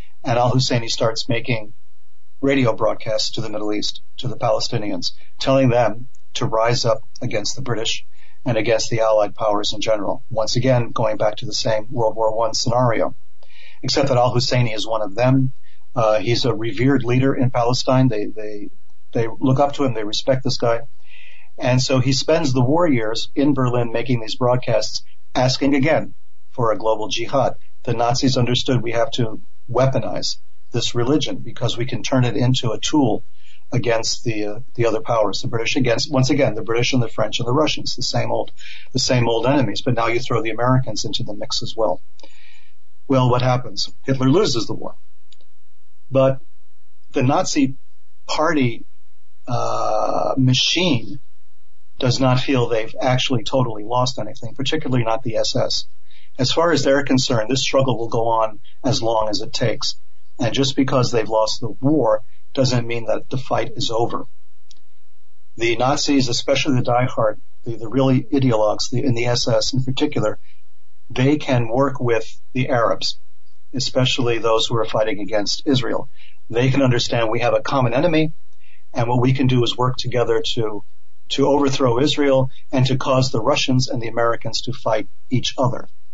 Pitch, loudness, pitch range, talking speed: 125 Hz, -20 LUFS, 115-130 Hz, 175 wpm